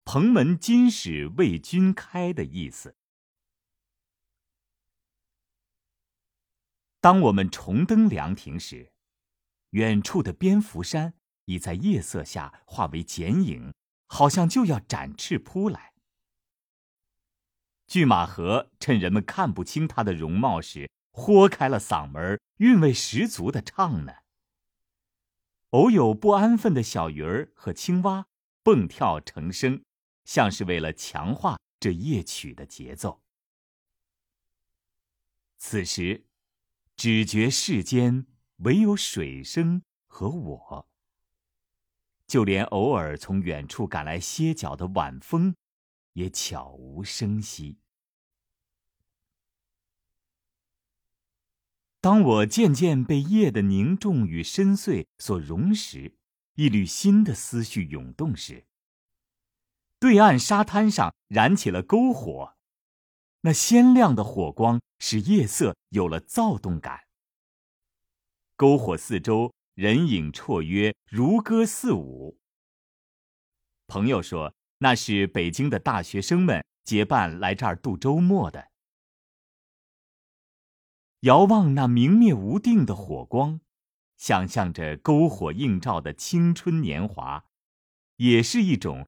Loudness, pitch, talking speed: -23 LUFS, 105 Hz, 155 characters per minute